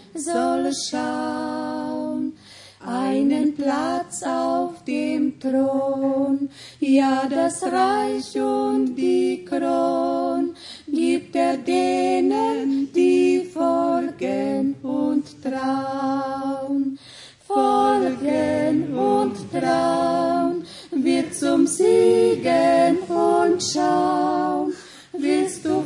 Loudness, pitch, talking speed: -21 LUFS, 275 Hz, 70 wpm